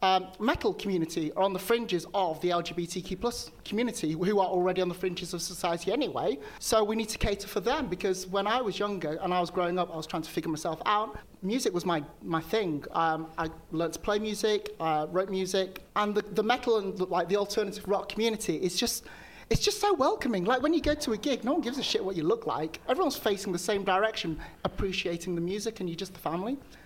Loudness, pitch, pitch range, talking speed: -30 LUFS, 190 Hz, 175-220 Hz, 245 wpm